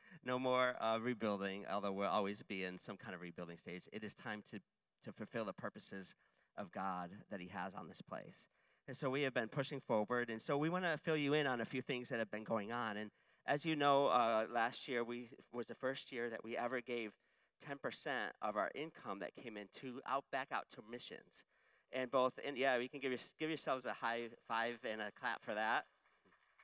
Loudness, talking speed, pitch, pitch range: -42 LUFS, 225 wpm, 120 Hz, 105-135 Hz